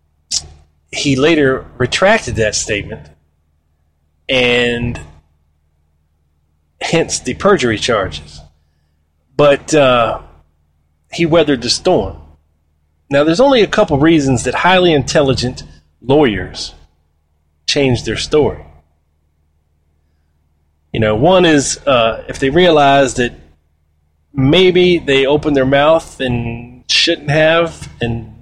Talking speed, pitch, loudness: 100 wpm, 80 Hz, -13 LUFS